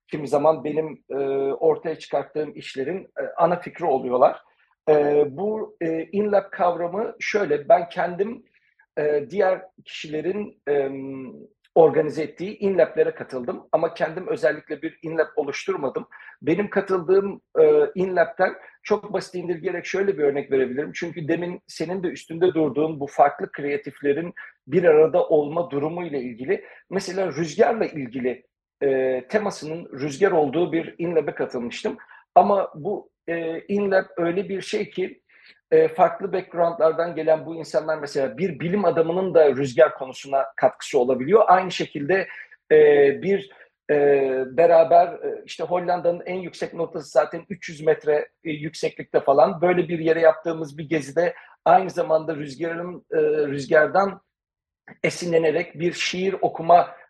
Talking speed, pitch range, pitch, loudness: 125 wpm, 155-195 Hz, 170 Hz, -22 LUFS